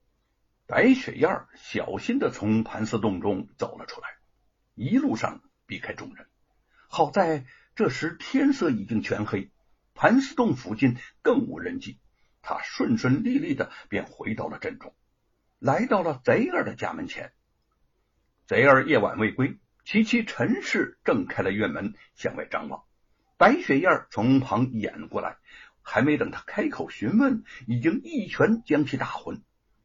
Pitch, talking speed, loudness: 150 Hz, 210 characters per minute, -25 LUFS